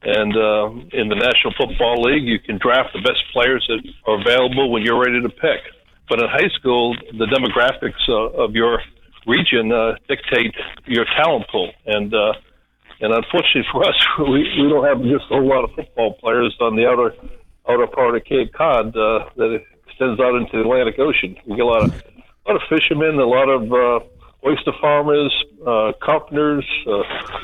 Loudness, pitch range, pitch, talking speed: -17 LUFS, 115-145 Hz, 125 Hz, 190 wpm